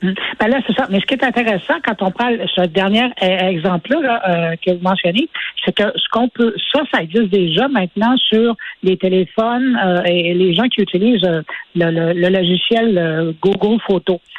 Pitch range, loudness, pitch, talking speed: 180-235 Hz, -15 LUFS, 195 Hz, 185 wpm